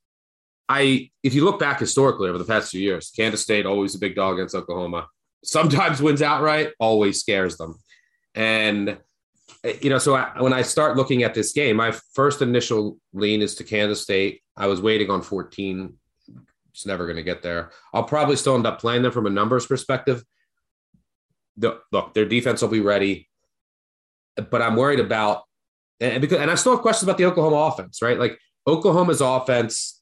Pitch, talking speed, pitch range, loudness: 115 Hz, 185 wpm, 100-135 Hz, -21 LUFS